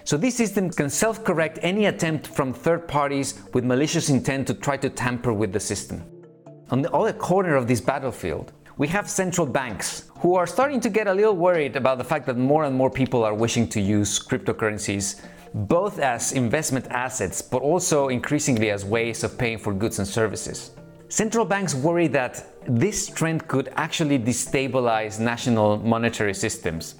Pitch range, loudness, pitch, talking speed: 115-165 Hz, -23 LUFS, 135 Hz, 180 wpm